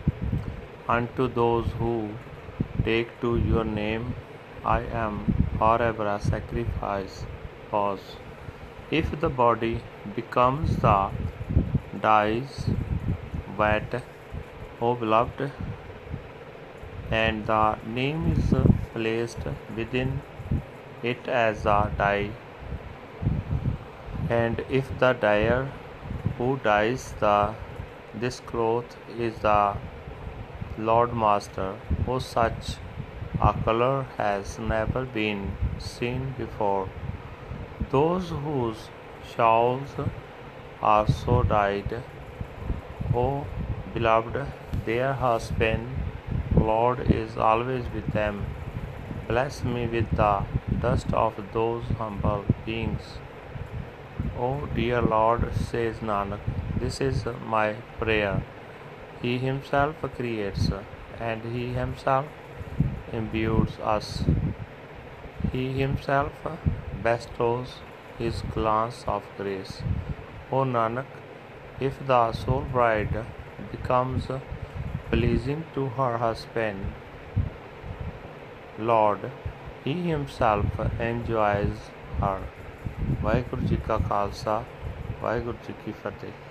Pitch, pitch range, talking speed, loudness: 115 Hz, 105-125 Hz, 85 wpm, -27 LUFS